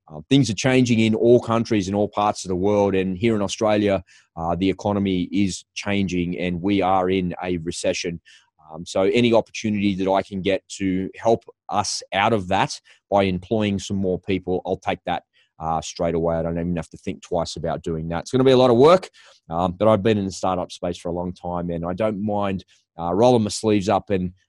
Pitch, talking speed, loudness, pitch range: 95 Hz, 230 wpm, -21 LUFS, 90-105 Hz